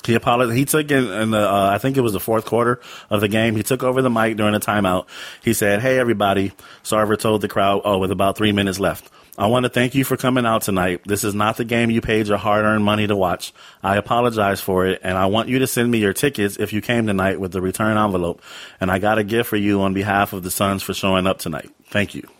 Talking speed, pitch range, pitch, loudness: 270 wpm, 100-115 Hz, 105 Hz, -19 LUFS